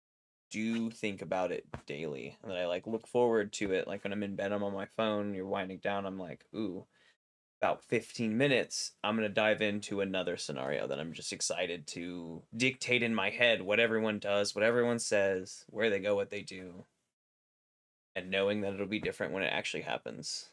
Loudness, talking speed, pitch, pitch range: -33 LUFS, 200 wpm, 100 Hz, 95-110 Hz